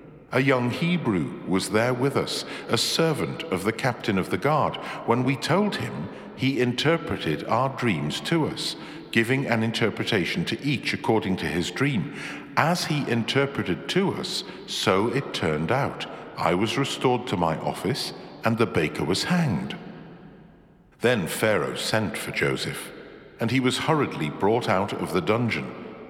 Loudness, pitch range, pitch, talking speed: -25 LUFS, 110-155 Hz, 125 Hz, 155 wpm